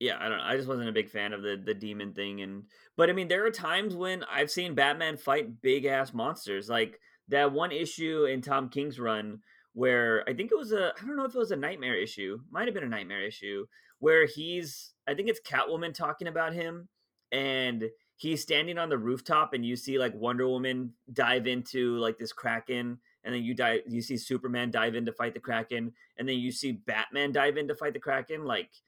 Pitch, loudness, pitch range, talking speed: 130 Hz, -30 LUFS, 120-160 Hz, 230 wpm